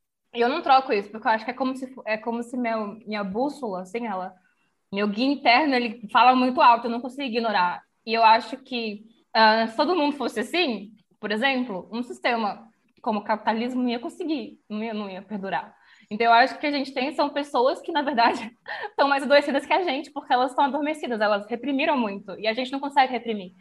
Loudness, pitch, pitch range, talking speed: -24 LUFS, 240 Hz, 220-280 Hz, 220 wpm